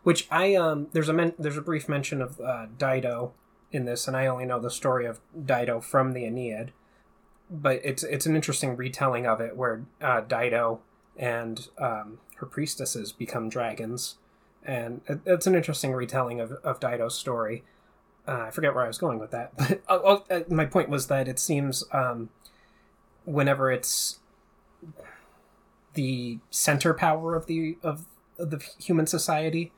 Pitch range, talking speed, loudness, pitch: 125-165 Hz, 165 wpm, -27 LUFS, 140 Hz